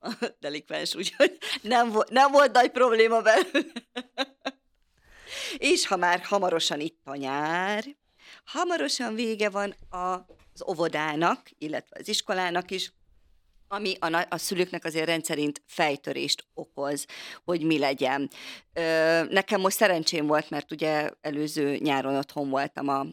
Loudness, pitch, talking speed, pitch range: -26 LUFS, 175 Hz, 115 wpm, 150-215 Hz